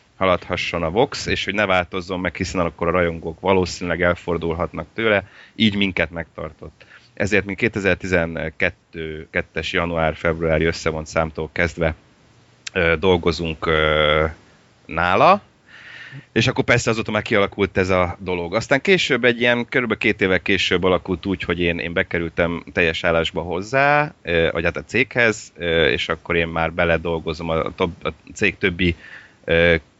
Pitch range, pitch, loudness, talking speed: 80-95 Hz, 90 Hz, -20 LUFS, 130 wpm